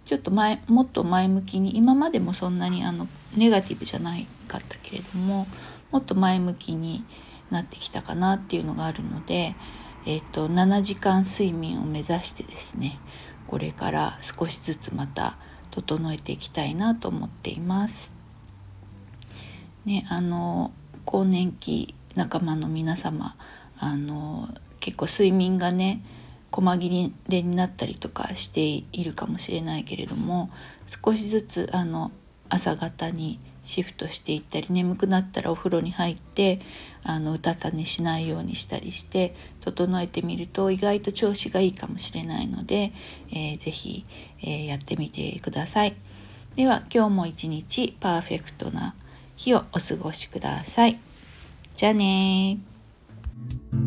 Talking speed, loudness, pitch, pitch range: 290 characters per minute, -25 LUFS, 175 Hz, 150-195 Hz